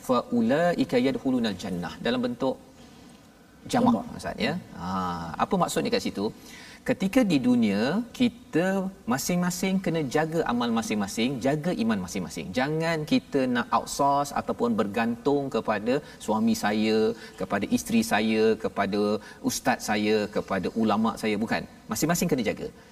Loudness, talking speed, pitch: -26 LUFS, 120 wpm, 195 Hz